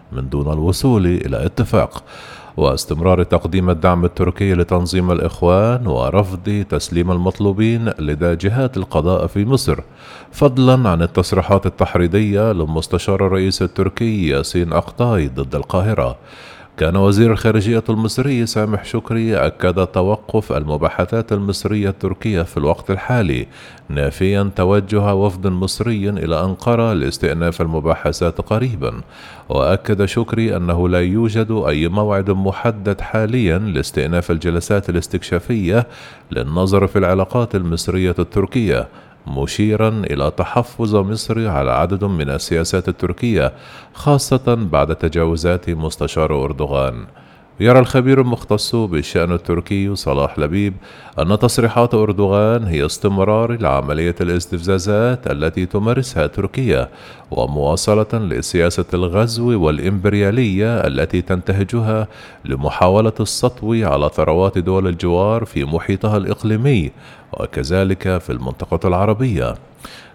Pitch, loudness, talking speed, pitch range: 95 Hz, -17 LUFS, 105 wpm, 85-110 Hz